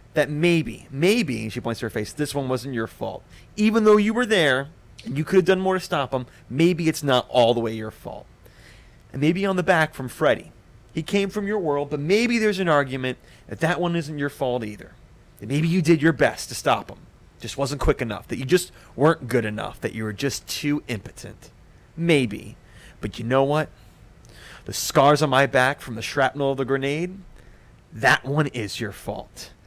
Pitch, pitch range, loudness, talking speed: 140 Hz, 120-160 Hz, -23 LUFS, 215 wpm